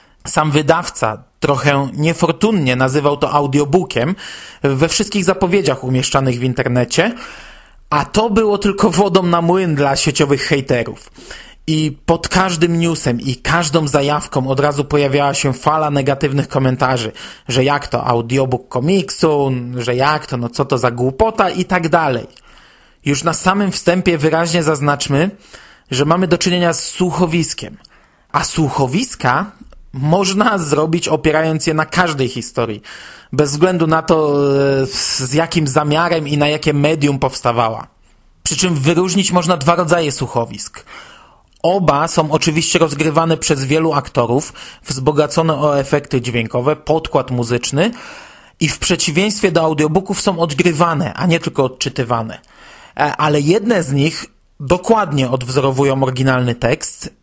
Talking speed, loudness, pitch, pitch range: 130 wpm, -15 LUFS, 150 Hz, 135-170 Hz